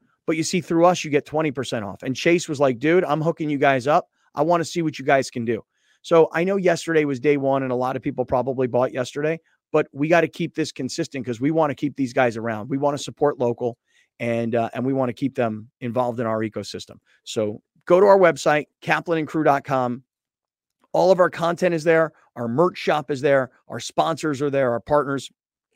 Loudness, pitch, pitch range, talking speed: -22 LUFS, 145 Hz, 125-160 Hz, 230 wpm